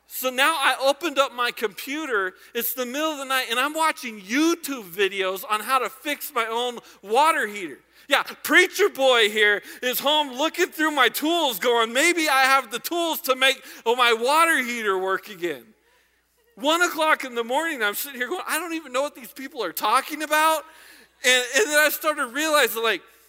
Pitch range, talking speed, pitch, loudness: 240-315 Hz, 195 wpm, 270 Hz, -22 LUFS